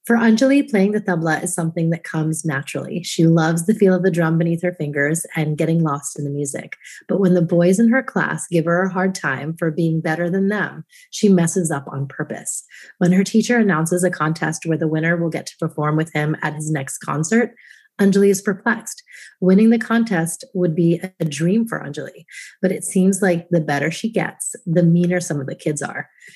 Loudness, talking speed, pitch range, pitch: -19 LUFS, 215 wpm, 160-195 Hz, 175 Hz